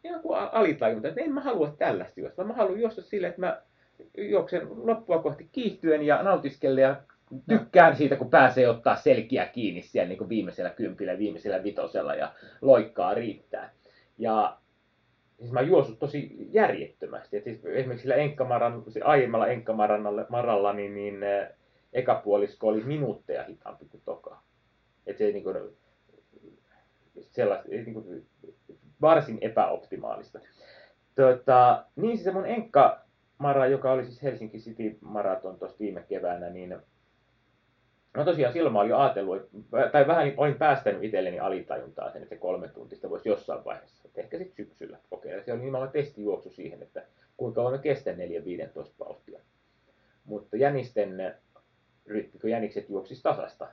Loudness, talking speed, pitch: -27 LUFS, 140 wpm, 140 Hz